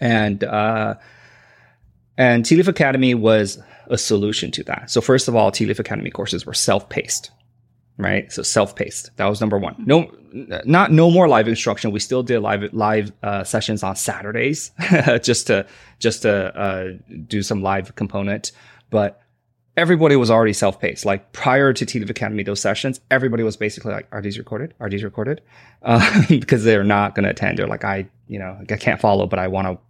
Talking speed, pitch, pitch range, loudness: 185 wpm, 110 Hz, 100-125 Hz, -18 LUFS